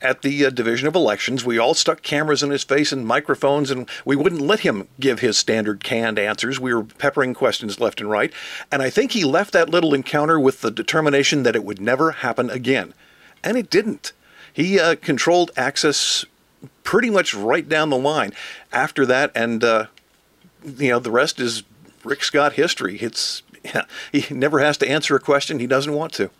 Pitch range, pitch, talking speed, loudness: 120-145 Hz, 135 Hz, 200 wpm, -19 LUFS